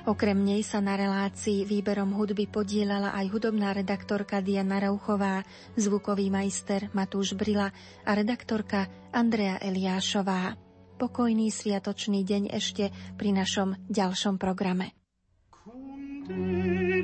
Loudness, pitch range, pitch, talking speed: -29 LUFS, 195-210 Hz, 200 Hz, 100 wpm